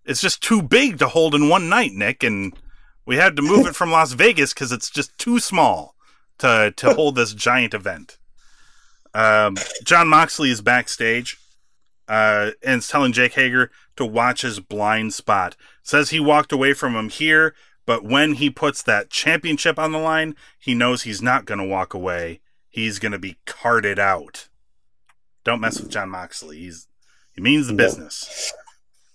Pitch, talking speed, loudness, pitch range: 125 Hz, 175 wpm, -18 LUFS, 110-155 Hz